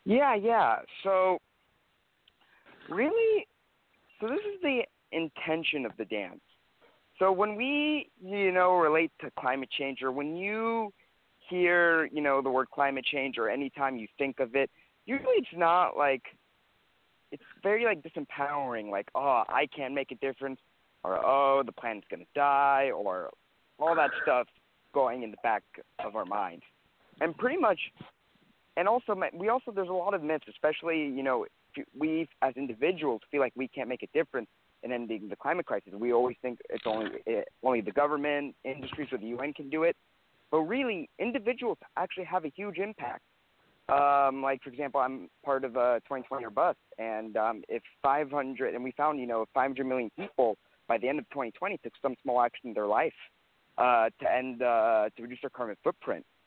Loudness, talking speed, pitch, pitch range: -30 LUFS, 180 wpm, 140 Hz, 130-185 Hz